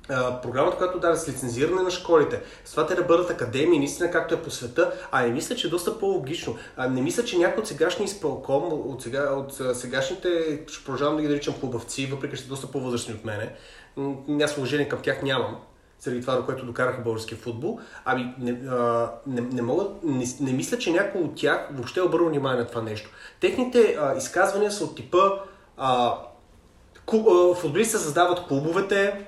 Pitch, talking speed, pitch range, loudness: 145 Hz, 195 wpm, 125-180 Hz, -25 LUFS